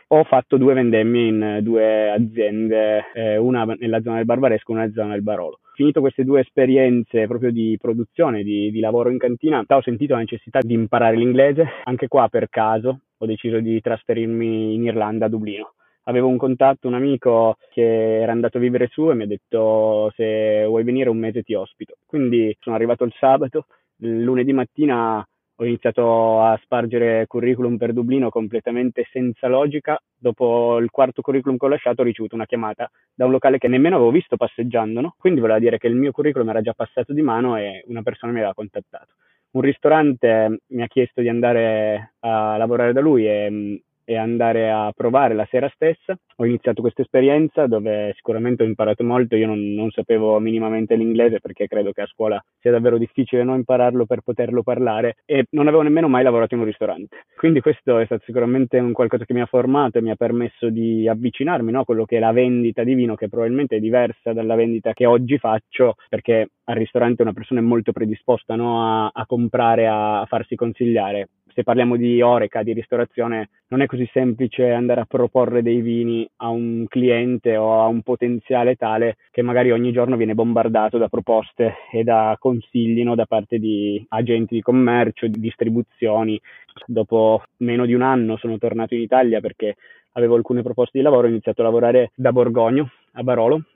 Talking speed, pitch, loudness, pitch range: 195 wpm, 120 Hz, -19 LUFS, 110-125 Hz